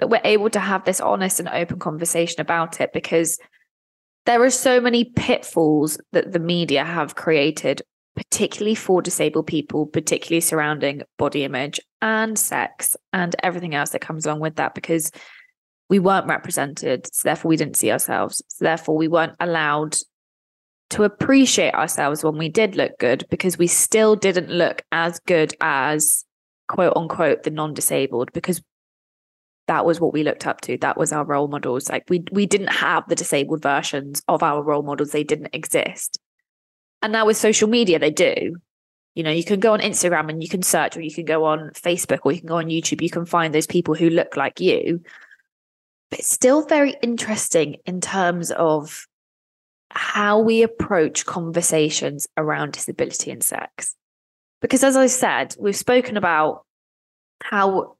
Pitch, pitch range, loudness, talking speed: 165 Hz, 155-200 Hz, -20 LUFS, 175 wpm